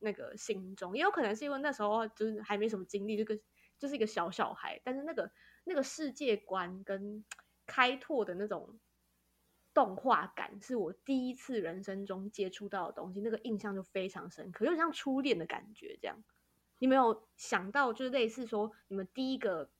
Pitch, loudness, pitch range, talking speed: 220 Hz, -36 LUFS, 200-260 Hz, 295 characters per minute